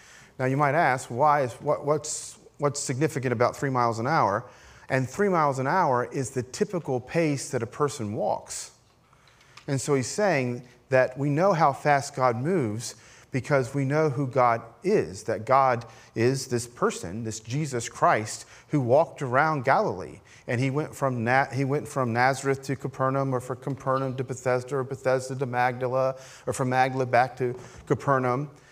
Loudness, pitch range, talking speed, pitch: -26 LUFS, 125-140 Hz, 175 wpm, 130 Hz